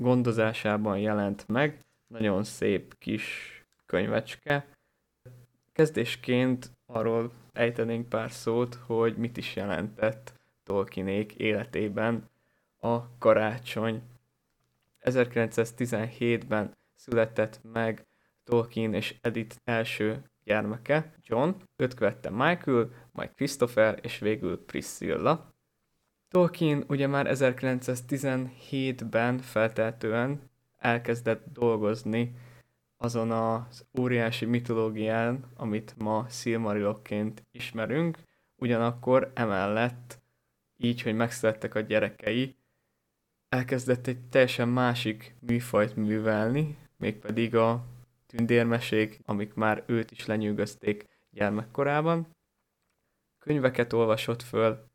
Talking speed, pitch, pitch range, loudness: 85 wpm, 115 Hz, 110-125 Hz, -29 LUFS